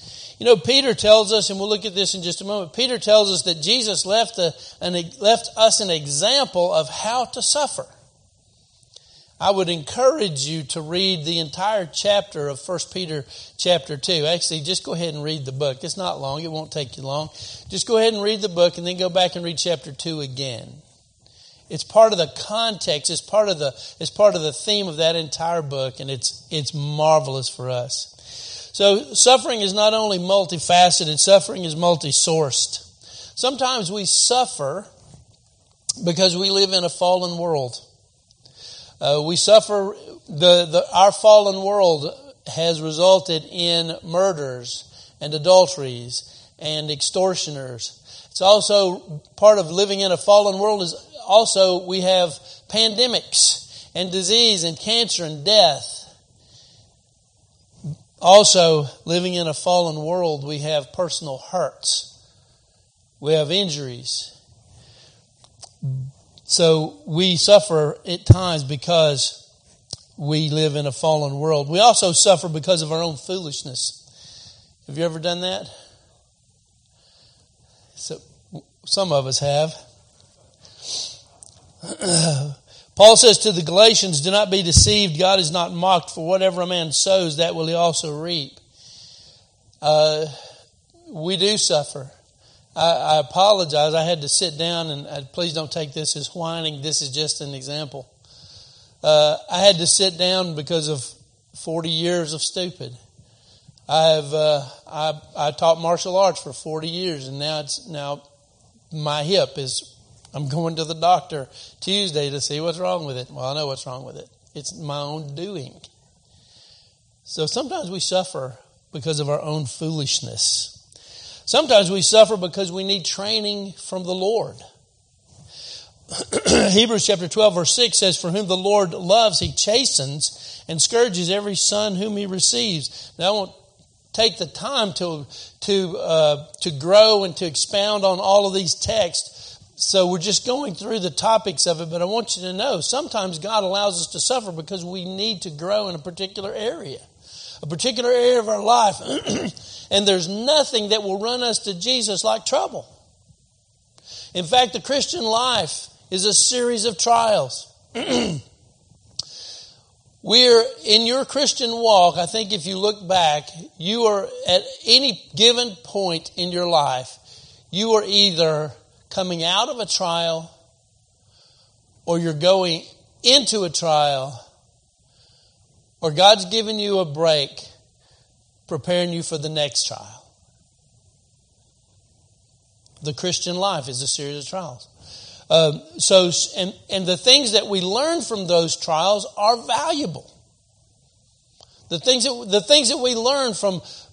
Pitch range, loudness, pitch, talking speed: 140-195 Hz, -19 LUFS, 165 Hz, 150 wpm